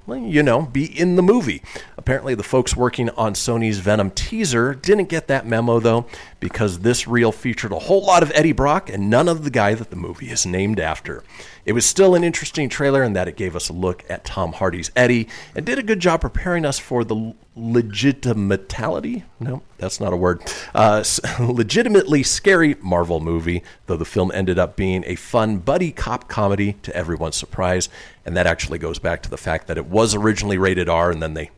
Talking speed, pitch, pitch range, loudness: 205 wpm, 115 Hz, 90-135 Hz, -19 LUFS